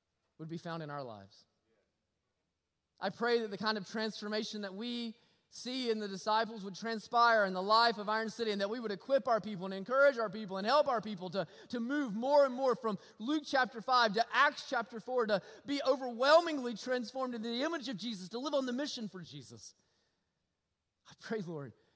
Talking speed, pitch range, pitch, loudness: 205 wpm, 200-250 Hz, 225 Hz, -34 LUFS